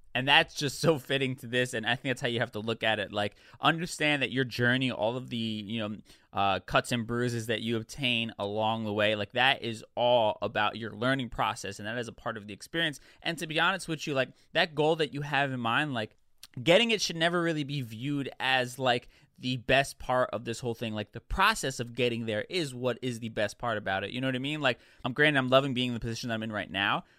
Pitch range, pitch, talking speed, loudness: 115-140 Hz, 125 Hz, 260 wpm, -29 LUFS